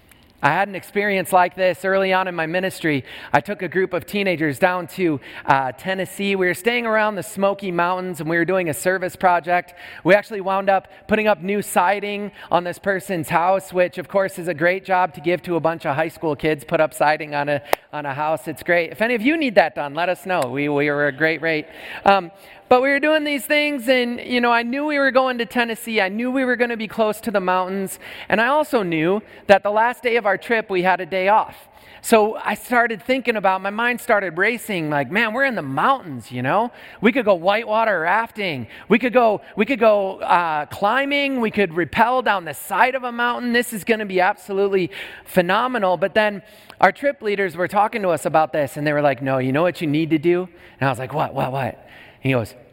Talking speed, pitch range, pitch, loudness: 240 wpm, 170-220 Hz, 190 Hz, -20 LUFS